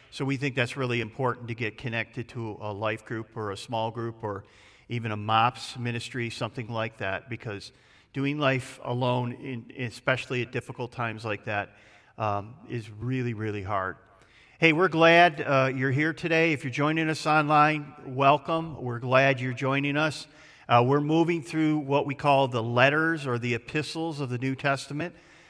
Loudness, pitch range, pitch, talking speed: -27 LUFS, 115-145 Hz, 130 Hz, 175 wpm